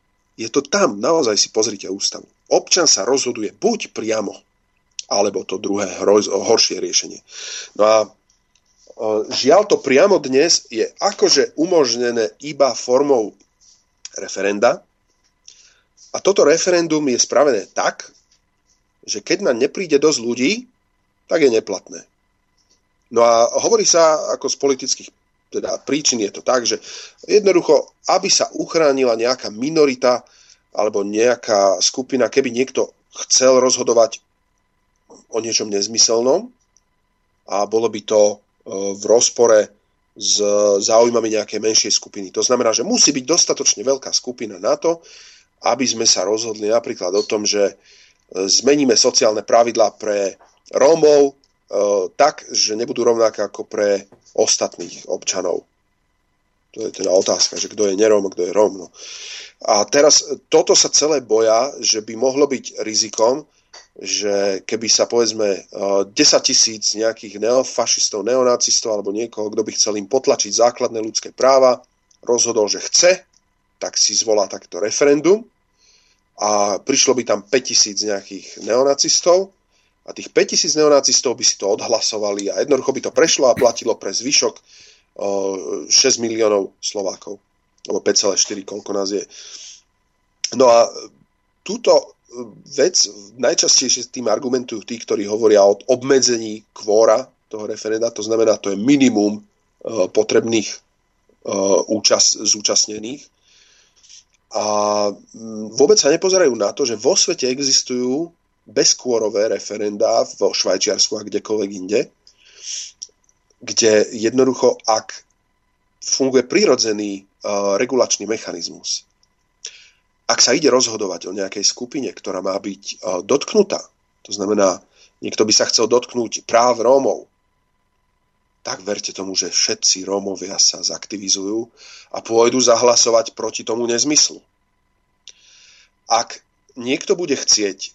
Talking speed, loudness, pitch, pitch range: 125 wpm, -16 LUFS, 115 Hz, 105-150 Hz